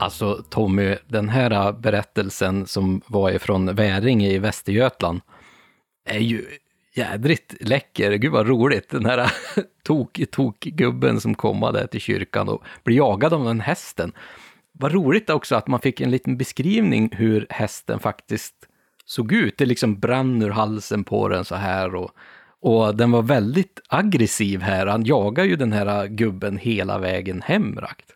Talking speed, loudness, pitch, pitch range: 155 wpm, -21 LUFS, 110 Hz, 100-125 Hz